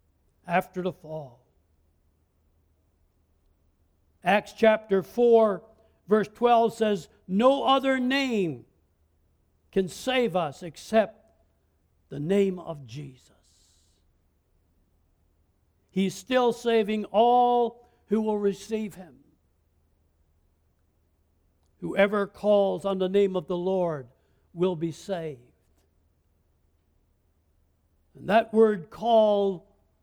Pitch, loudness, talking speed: 150 Hz, -25 LUFS, 85 wpm